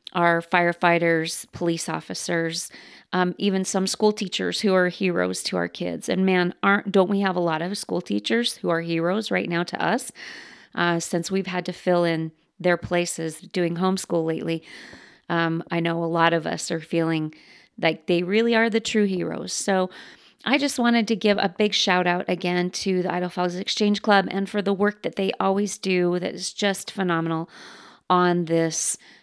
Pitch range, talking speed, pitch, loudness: 170-195 Hz, 190 wpm, 180 Hz, -23 LUFS